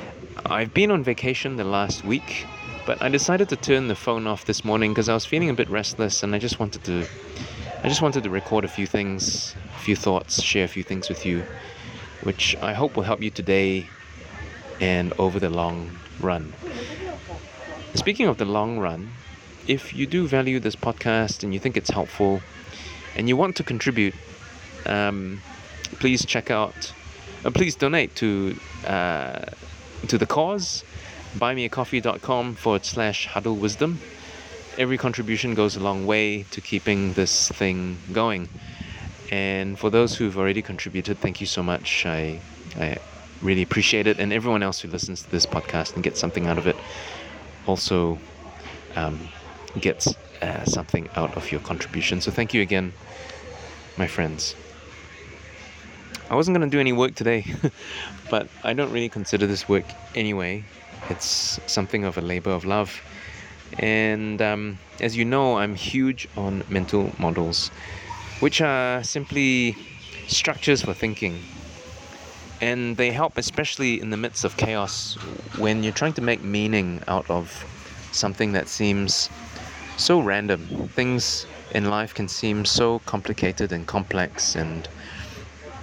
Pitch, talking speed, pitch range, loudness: 100 Hz, 155 wpm, 90-115 Hz, -24 LUFS